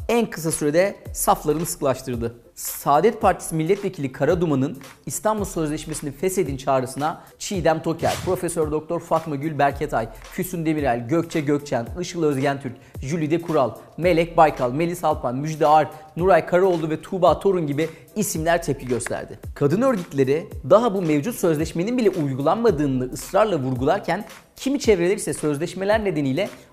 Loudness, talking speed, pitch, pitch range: -22 LUFS, 130 wpm, 160 Hz, 145-180 Hz